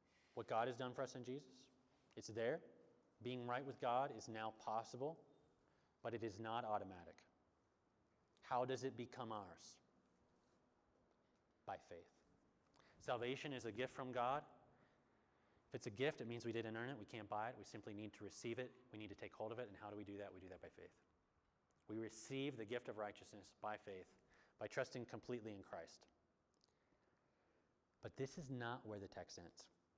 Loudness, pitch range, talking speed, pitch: -50 LUFS, 105-125 Hz, 190 wpm, 115 Hz